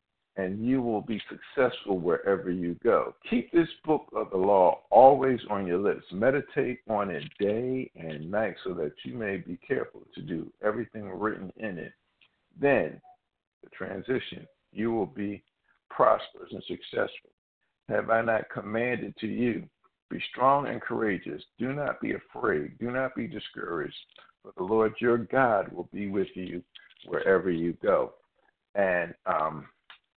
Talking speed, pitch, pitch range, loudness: 155 wpm, 110 Hz, 95-120 Hz, -28 LUFS